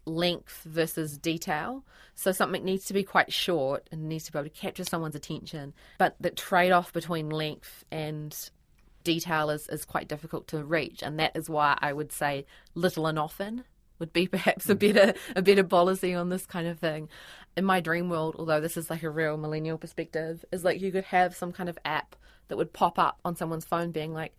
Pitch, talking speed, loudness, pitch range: 165 Hz, 210 wpm, -29 LUFS, 155-180 Hz